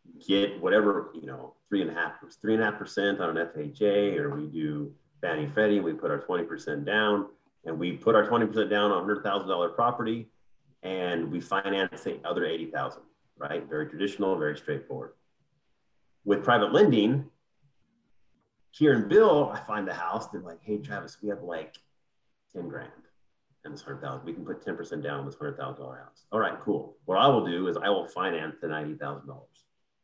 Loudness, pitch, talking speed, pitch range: -28 LUFS, 100 Hz, 185 wpm, 80-105 Hz